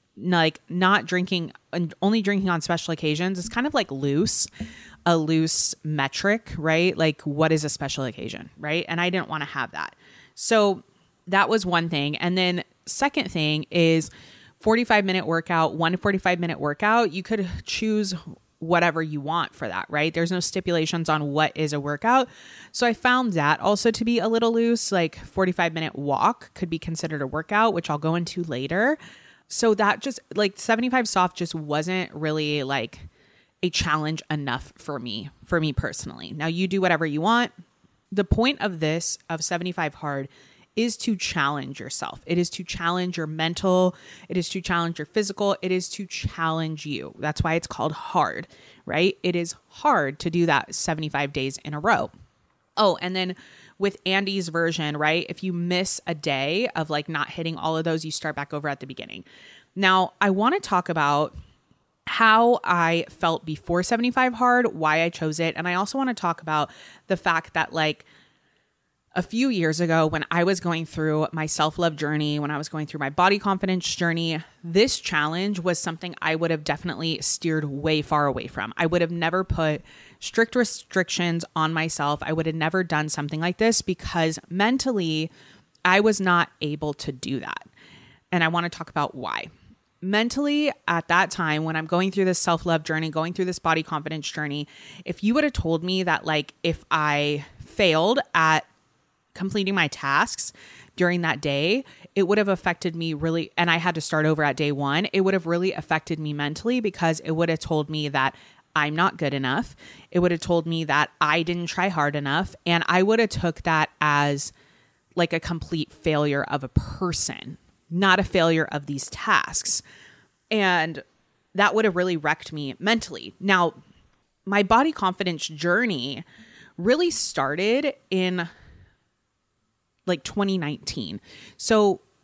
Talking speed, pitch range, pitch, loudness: 180 wpm, 155-185 Hz, 170 Hz, -24 LUFS